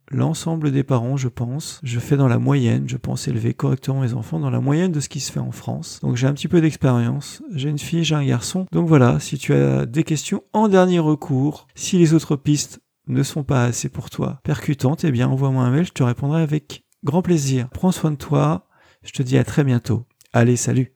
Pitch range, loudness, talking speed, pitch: 130-160 Hz, -20 LUFS, 235 wpm, 140 Hz